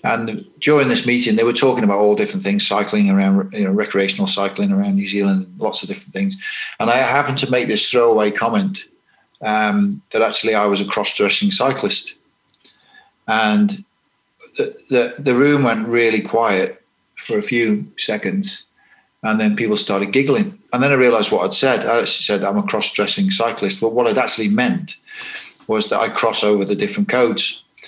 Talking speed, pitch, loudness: 180 wpm, 150 Hz, -17 LUFS